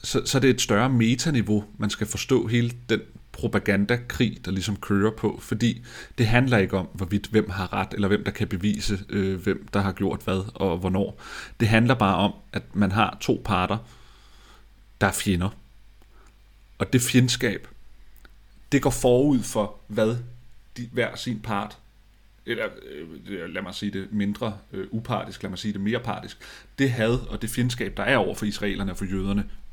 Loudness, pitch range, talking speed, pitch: -25 LUFS, 100-120 Hz, 185 wpm, 105 Hz